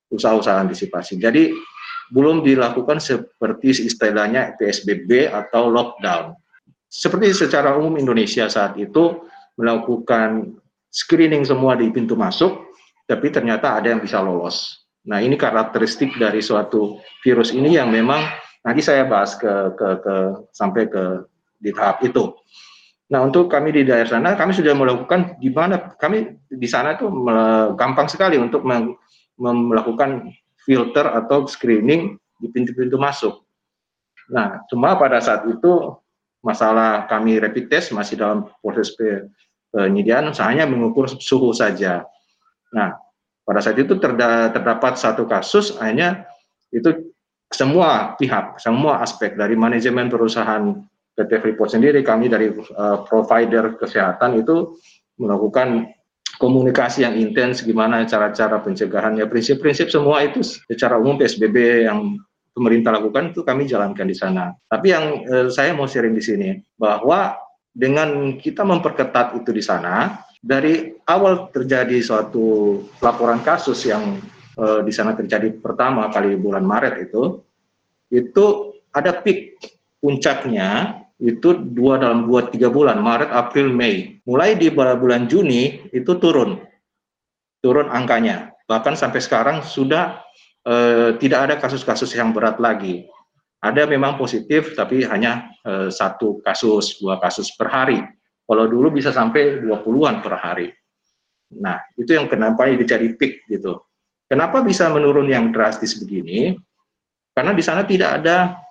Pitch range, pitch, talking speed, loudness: 115-155 Hz, 125 Hz, 130 wpm, -18 LUFS